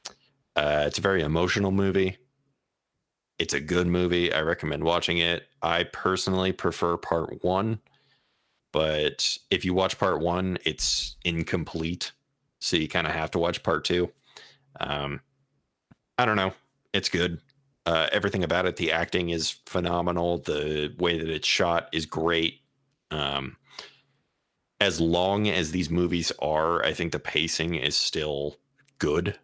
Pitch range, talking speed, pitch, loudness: 80-95 Hz, 145 wpm, 85 Hz, -26 LUFS